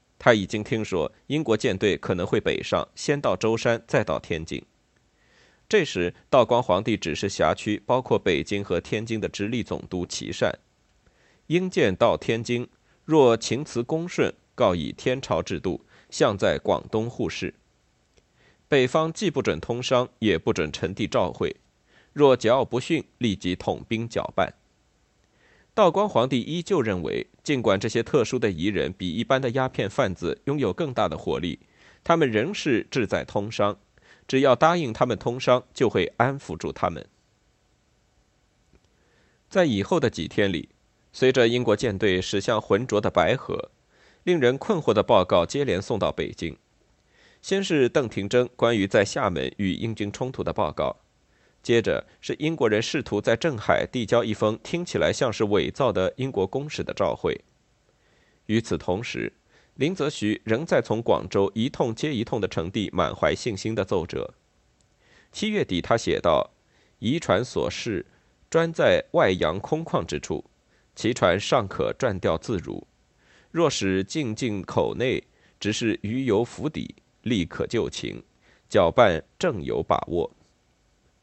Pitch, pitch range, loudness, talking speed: 115 Hz, 100-130 Hz, -25 LUFS, 225 characters per minute